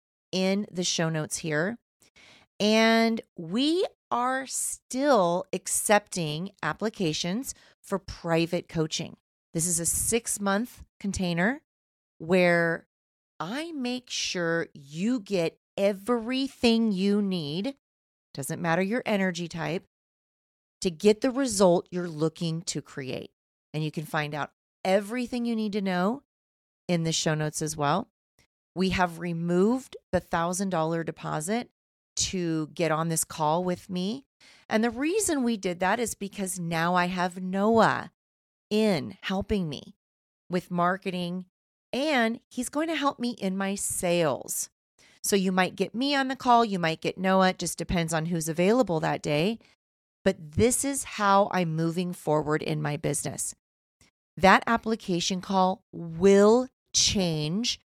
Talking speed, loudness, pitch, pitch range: 140 wpm, -27 LUFS, 185 Hz, 165-225 Hz